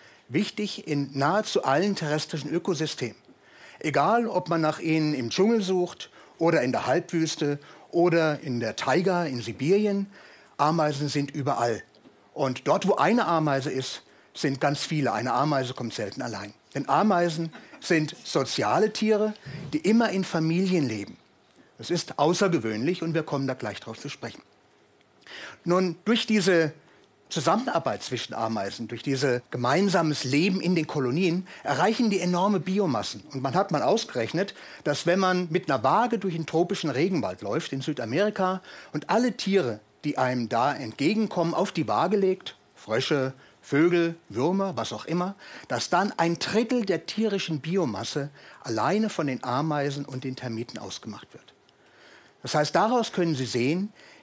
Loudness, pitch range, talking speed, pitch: -26 LUFS, 140-190 Hz, 150 wpm, 165 Hz